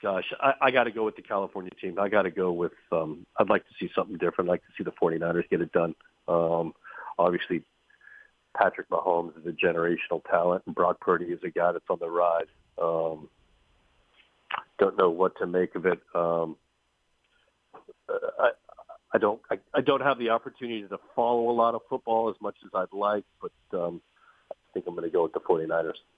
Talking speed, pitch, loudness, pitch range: 205 wpm, 110 Hz, -28 LUFS, 85-125 Hz